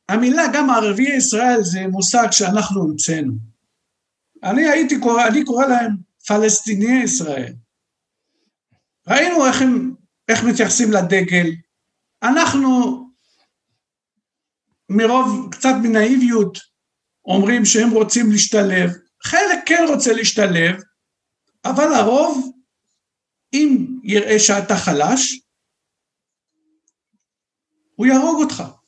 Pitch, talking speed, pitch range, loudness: 235 Hz, 90 wpm, 205-260 Hz, -16 LUFS